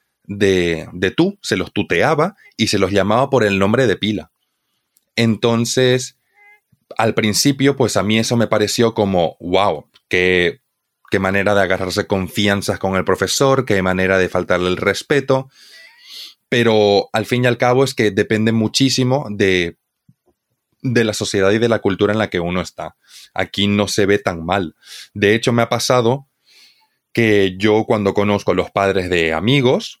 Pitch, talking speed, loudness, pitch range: 105 Hz, 170 wpm, -16 LUFS, 95-120 Hz